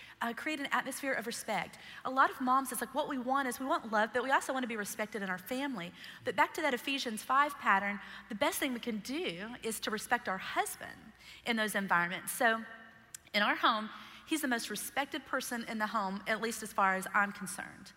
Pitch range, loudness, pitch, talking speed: 215-270 Hz, -34 LUFS, 235 Hz, 230 wpm